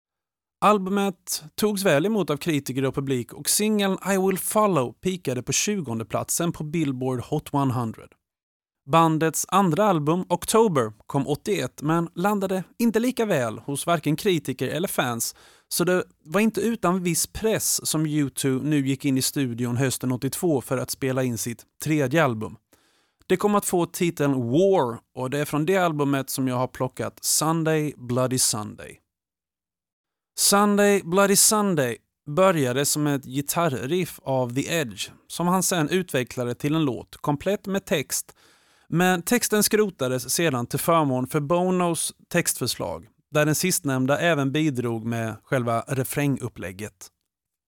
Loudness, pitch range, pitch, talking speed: -23 LUFS, 130-185 Hz, 150 Hz, 145 wpm